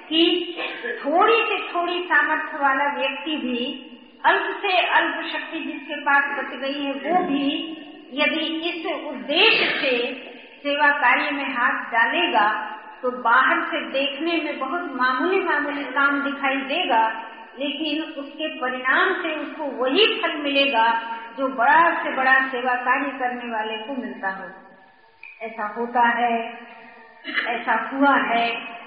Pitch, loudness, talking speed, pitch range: 280 Hz, -21 LUFS, 135 wpm, 245-310 Hz